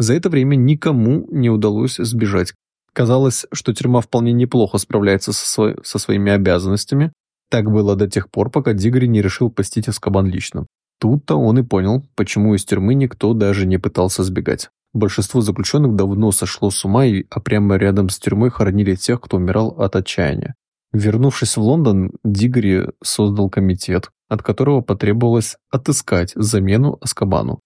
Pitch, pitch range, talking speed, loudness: 105 Hz, 100-120 Hz, 155 wpm, -17 LUFS